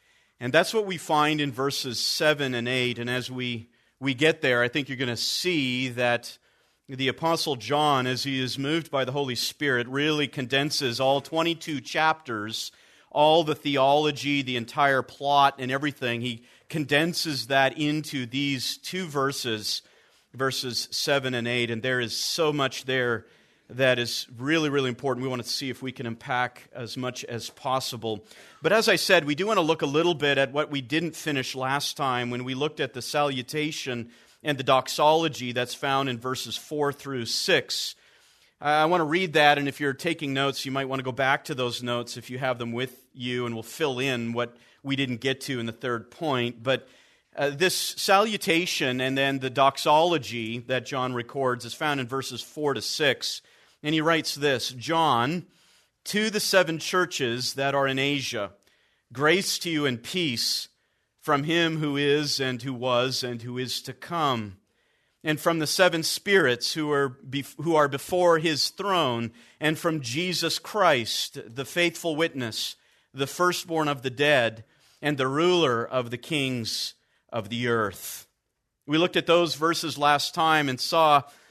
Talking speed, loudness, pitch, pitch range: 180 wpm, -25 LUFS, 135 Hz, 125-155 Hz